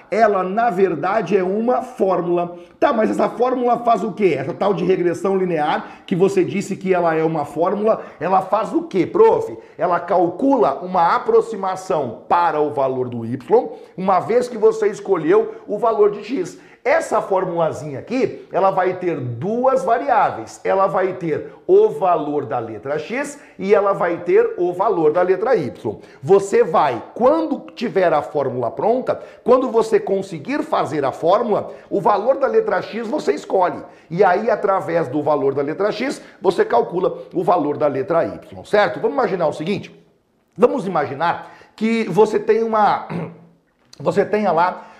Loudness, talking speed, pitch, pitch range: -18 LUFS, 165 wpm, 205 Hz, 175-275 Hz